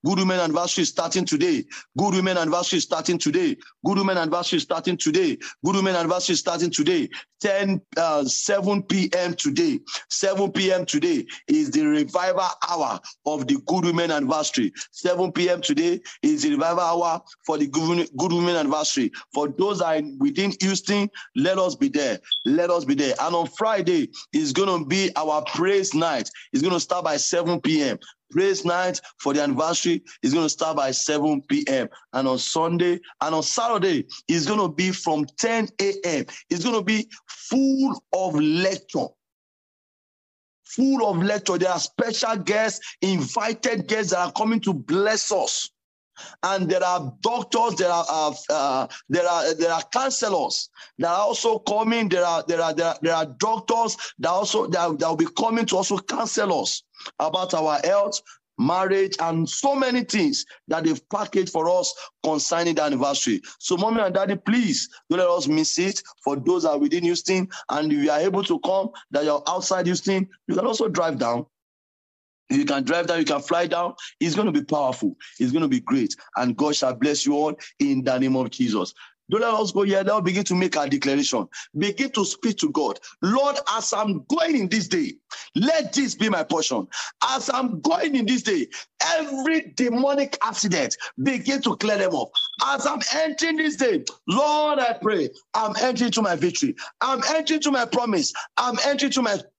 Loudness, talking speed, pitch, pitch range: -23 LUFS, 180 wpm, 200 Hz, 175-275 Hz